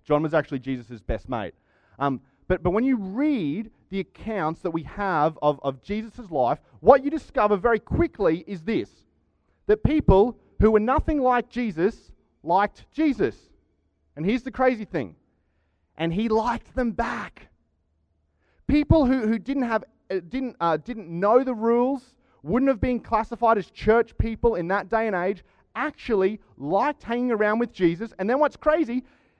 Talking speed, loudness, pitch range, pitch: 165 wpm, -24 LUFS, 165-245 Hz, 215 Hz